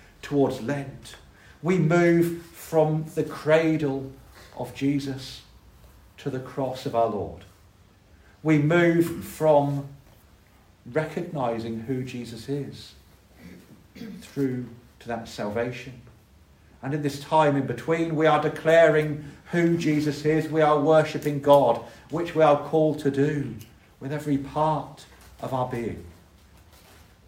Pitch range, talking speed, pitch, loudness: 115-155 Hz, 120 wpm, 140 Hz, -24 LUFS